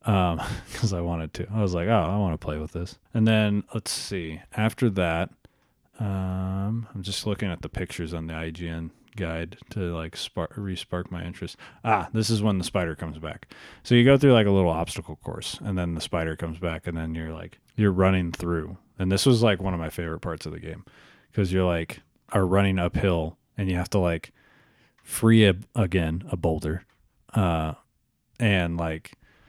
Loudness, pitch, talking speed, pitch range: -26 LUFS, 90 Hz, 200 wpm, 85-105 Hz